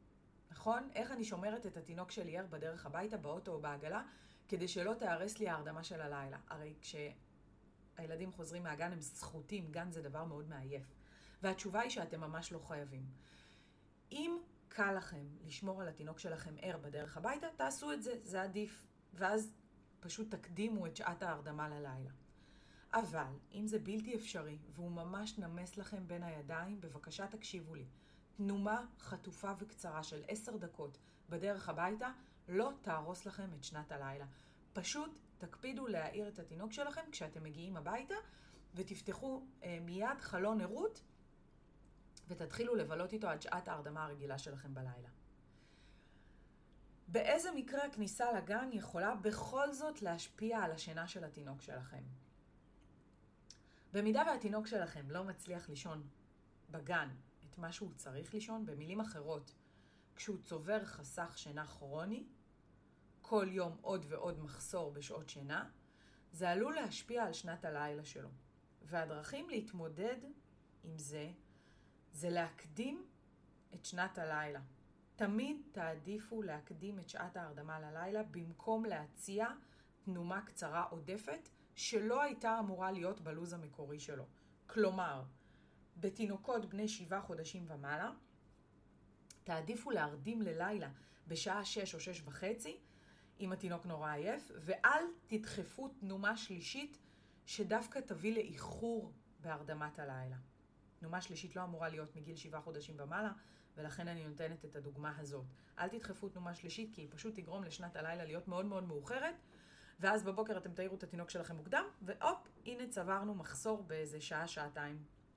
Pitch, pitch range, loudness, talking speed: 180 Hz, 155-215 Hz, -44 LUFS, 130 wpm